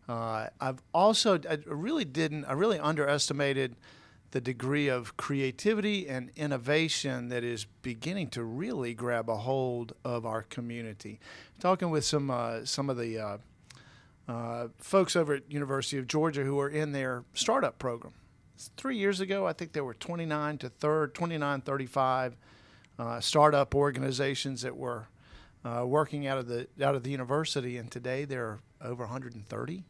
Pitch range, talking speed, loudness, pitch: 120-150 Hz, 160 wpm, -31 LUFS, 135 Hz